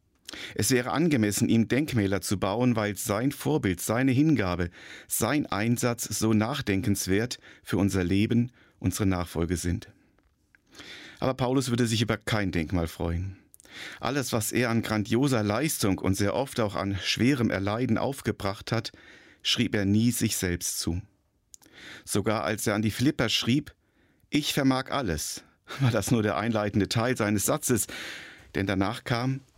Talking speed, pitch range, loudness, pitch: 145 wpm, 100-125 Hz, -27 LUFS, 110 Hz